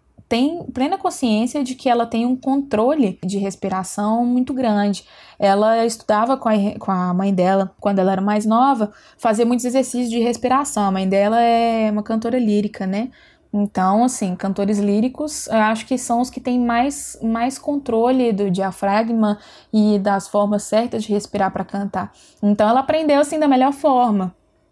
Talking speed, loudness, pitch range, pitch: 170 wpm, -19 LUFS, 205-250 Hz, 225 Hz